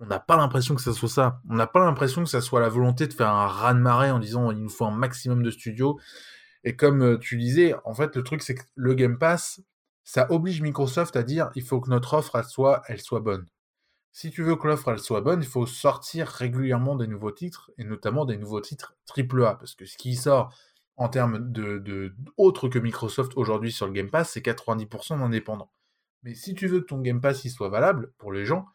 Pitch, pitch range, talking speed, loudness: 125 Hz, 115-145 Hz, 240 wpm, -25 LUFS